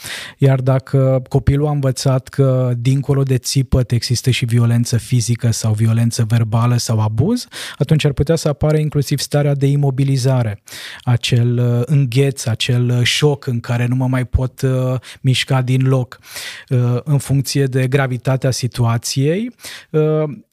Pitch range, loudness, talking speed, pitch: 120-140 Hz, -16 LUFS, 130 wpm, 130 Hz